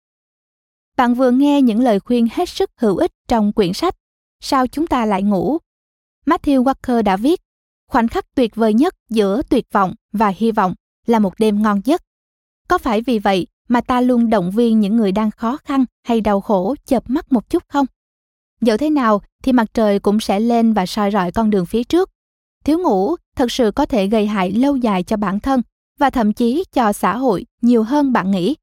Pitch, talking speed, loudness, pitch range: 235 Hz, 210 wpm, -17 LUFS, 210-270 Hz